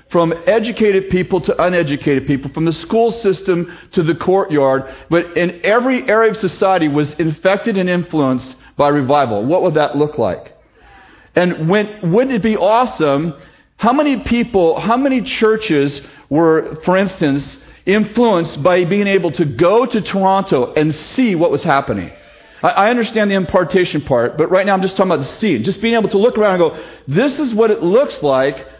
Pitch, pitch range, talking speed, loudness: 180 Hz, 155-210 Hz, 180 wpm, -15 LUFS